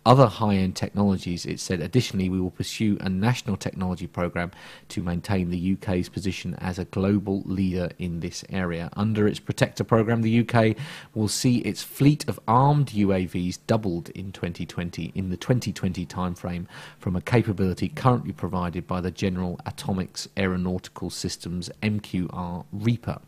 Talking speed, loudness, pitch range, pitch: 150 wpm, -26 LUFS, 90-110 Hz, 95 Hz